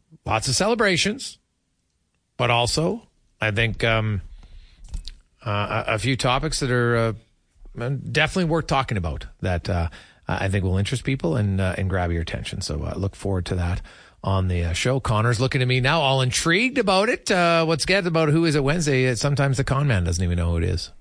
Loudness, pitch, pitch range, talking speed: -22 LUFS, 115 Hz, 90-140 Hz, 195 wpm